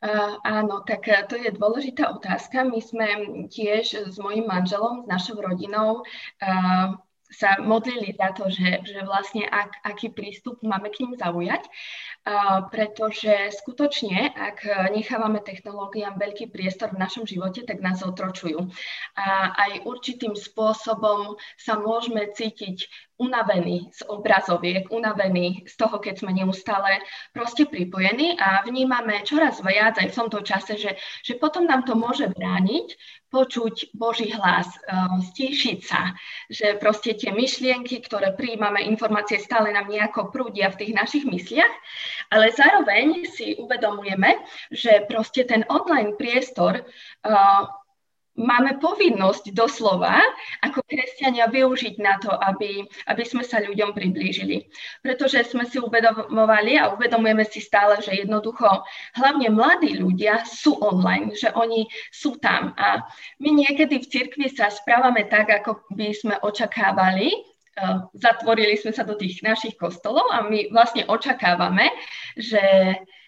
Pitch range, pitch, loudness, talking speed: 195-240 Hz, 215 Hz, -22 LUFS, 135 wpm